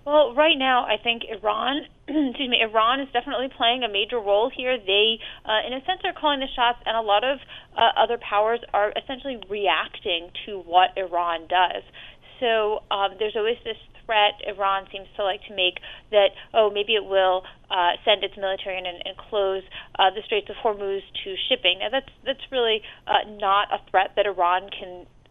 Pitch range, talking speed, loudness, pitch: 195-245 Hz, 190 wpm, -23 LUFS, 210 Hz